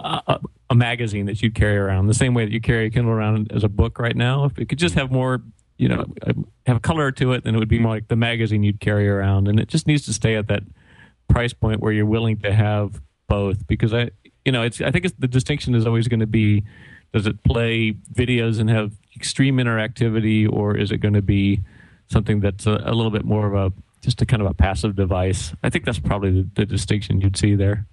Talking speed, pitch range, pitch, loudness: 245 wpm, 105-120 Hz, 110 Hz, -20 LUFS